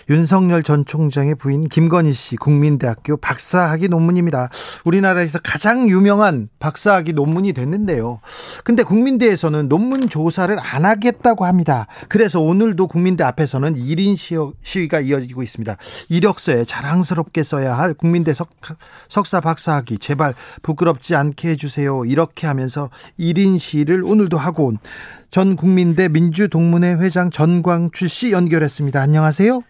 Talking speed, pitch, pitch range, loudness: 345 characters per minute, 165 Hz, 145-185 Hz, -16 LUFS